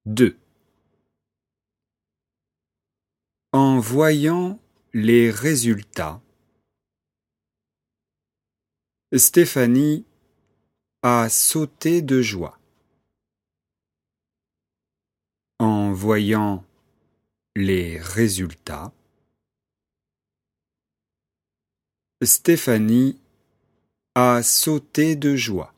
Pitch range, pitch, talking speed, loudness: 100-135 Hz, 115 Hz, 45 wpm, -19 LUFS